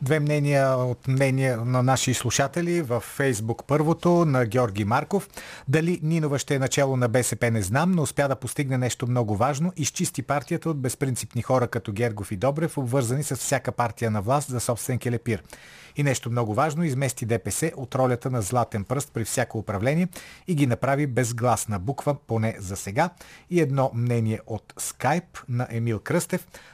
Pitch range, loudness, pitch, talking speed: 120-145 Hz, -25 LUFS, 130 Hz, 175 wpm